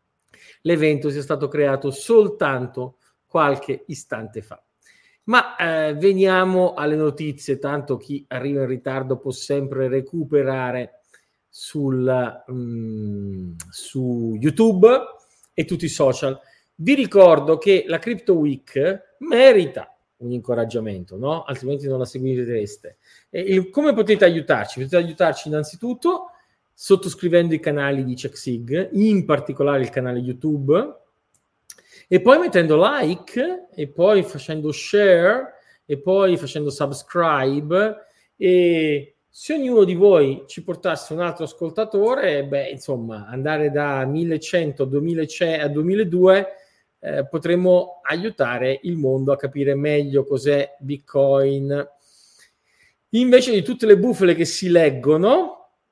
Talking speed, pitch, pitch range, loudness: 120 wpm, 150 Hz, 135-185 Hz, -19 LUFS